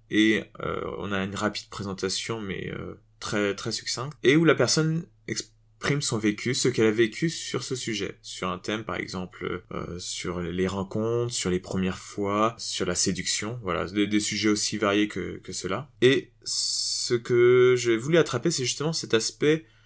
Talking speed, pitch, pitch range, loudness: 185 wpm, 110 Hz, 100-120 Hz, -26 LUFS